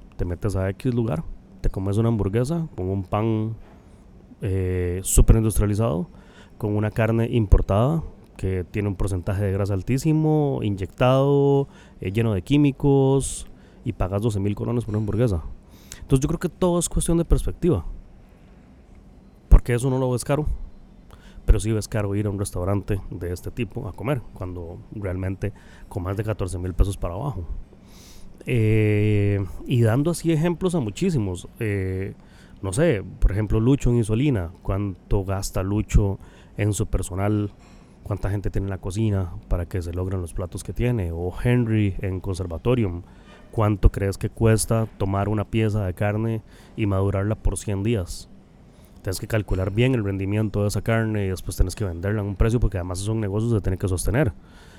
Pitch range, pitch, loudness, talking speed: 95-115 Hz, 105 Hz, -24 LUFS, 170 wpm